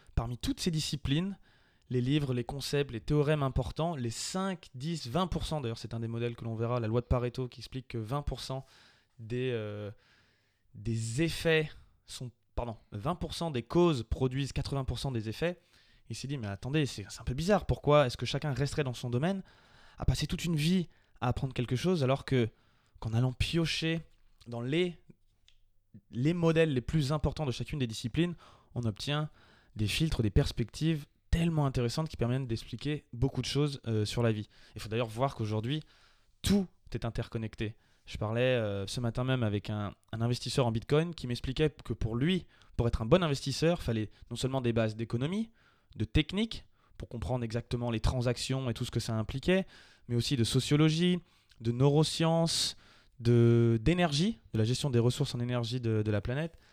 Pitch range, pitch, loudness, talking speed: 115-150 Hz, 125 Hz, -32 LUFS, 185 wpm